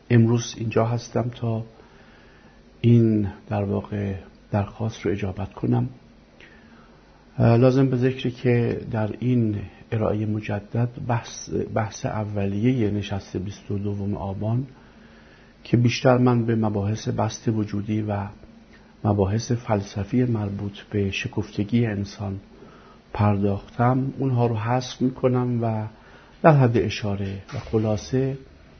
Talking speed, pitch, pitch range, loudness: 110 wpm, 110 Hz, 100-120 Hz, -24 LUFS